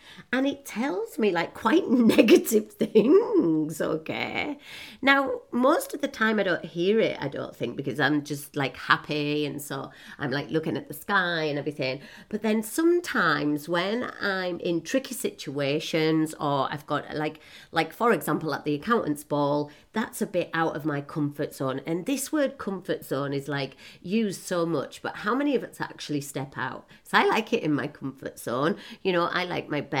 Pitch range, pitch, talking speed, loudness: 150-225 Hz, 170 Hz, 190 wpm, -26 LUFS